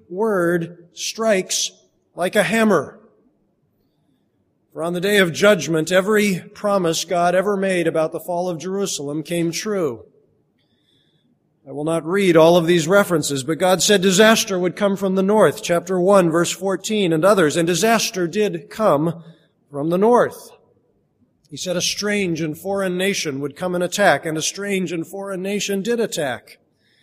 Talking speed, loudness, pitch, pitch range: 160 wpm, -18 LUFS, 185 Hz, 165-200 Hz